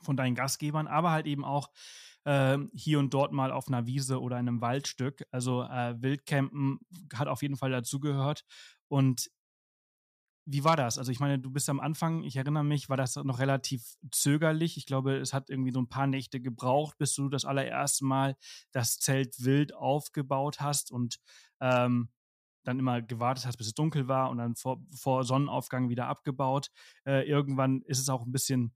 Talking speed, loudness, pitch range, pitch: 185 wpm, -31 LUFS, 130-145 Hz, 135 Hz